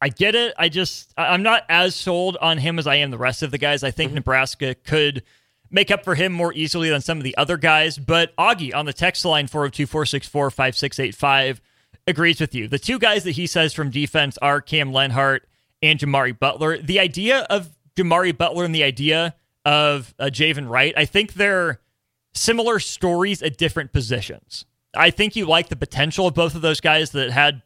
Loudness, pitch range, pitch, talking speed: -19 LUFS, 140-175 Hz, 155 Hz, 195 wpm